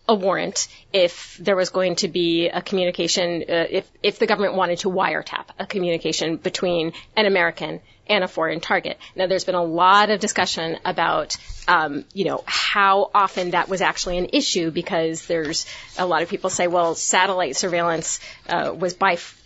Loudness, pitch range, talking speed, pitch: -21 LUFS, 170-195 Hz, 180 wpm, 185 Hz